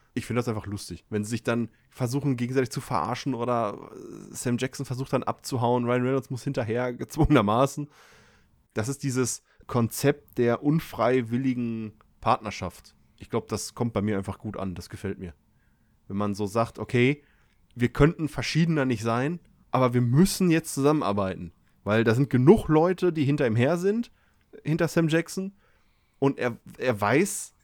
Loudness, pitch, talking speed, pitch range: -26 LUFS, 125 Hz, 165 wpm, 110-140 Hz